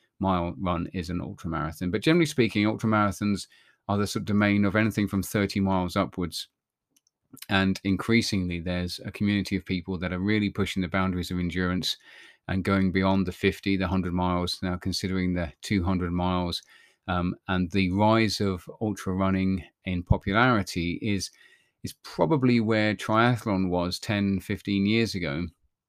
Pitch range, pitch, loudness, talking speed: 90-105 Hz, 95 Hz, -26 LUFS, 160 wpm